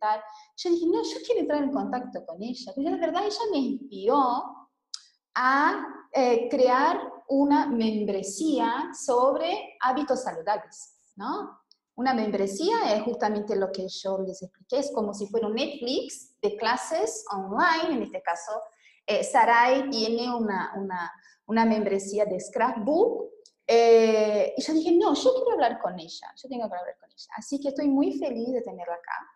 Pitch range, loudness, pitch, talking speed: 215-295 Hz, -26 LUFS, 245 Hz, 160 wpm